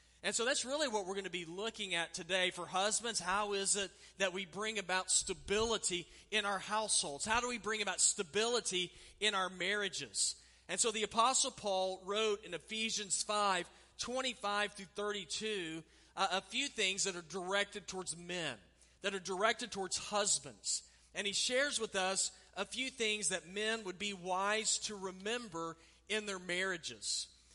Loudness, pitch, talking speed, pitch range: -36 LUFS, 195 Hz, 175 wpm, 180-215 Hz